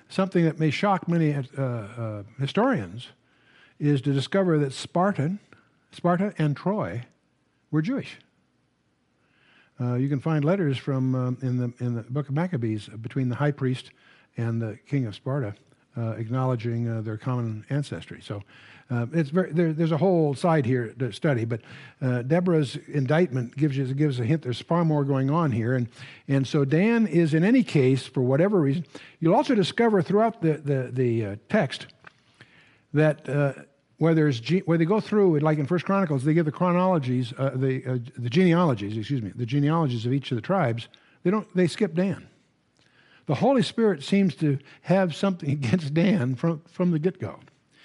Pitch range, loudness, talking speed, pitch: 125-170 Hz, -25 LUFS, 180 wpm, 145 Hz